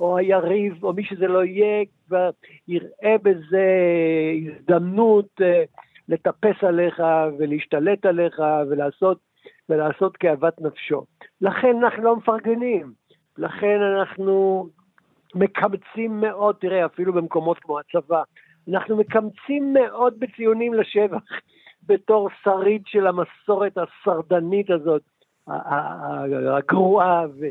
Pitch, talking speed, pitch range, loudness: 190 Hz, 95 wpm, 170-210 Hz, -21 LUFS